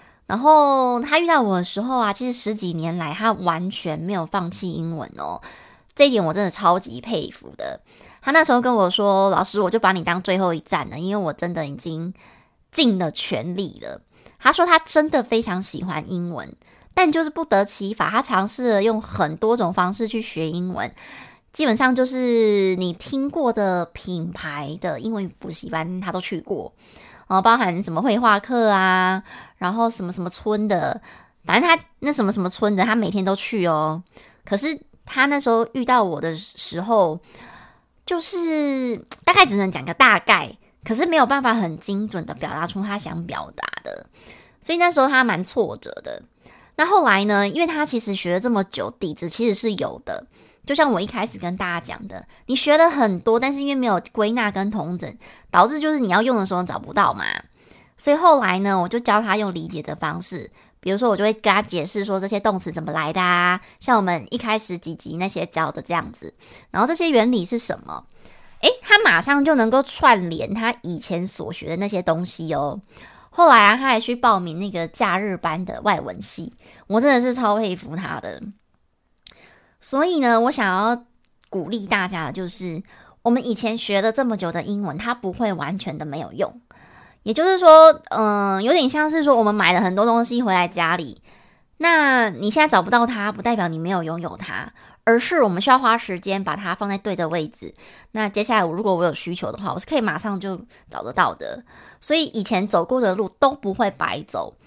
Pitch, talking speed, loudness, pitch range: 205 Hz, 285 characters per minute, -20 LUFS, 180-245 Hz